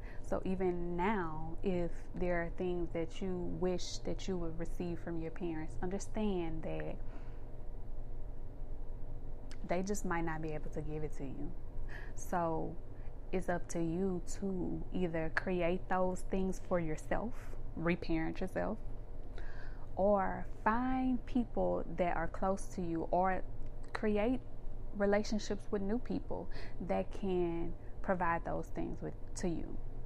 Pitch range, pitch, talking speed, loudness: 120-185 Hz, 170 Hz, 130 wpm, -38 LUFS